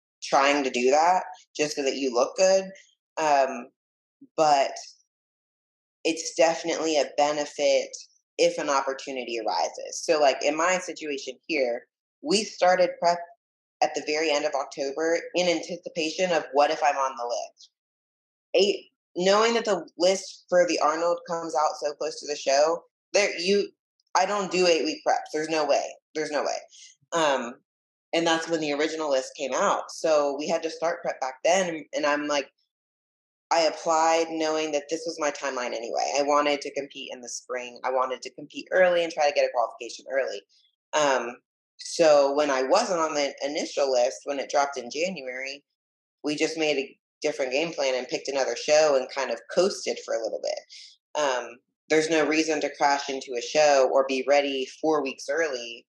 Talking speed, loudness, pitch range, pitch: 185 wpm, -25 LUFS, 140-180 Hz, 155 Hz